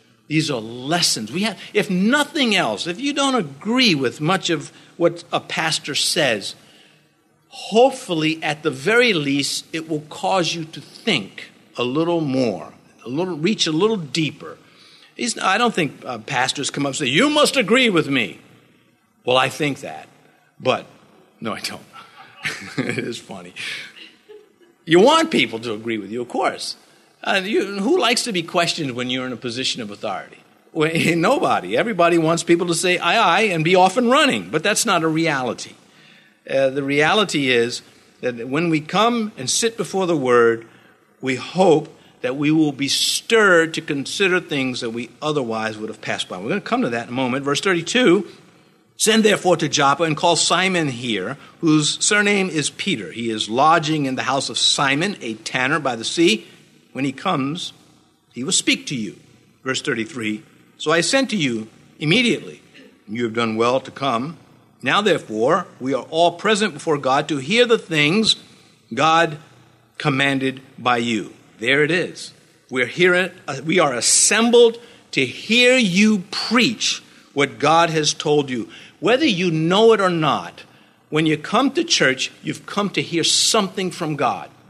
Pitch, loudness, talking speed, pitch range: 160 Hz, -19 LUFS, 175 wpm, 135-190 Hz